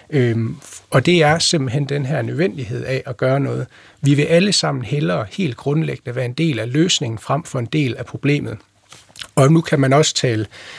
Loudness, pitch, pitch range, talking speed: -18 LUFS, 140 Hz, 120-155 Hz, 200 wpm